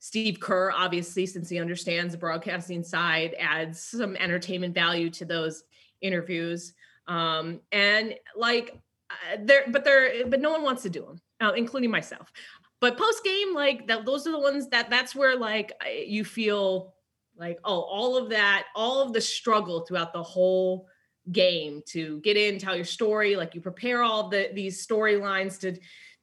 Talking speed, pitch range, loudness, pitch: 170 wpm, 175-235 Hz, -26 LUFS, 195 Hz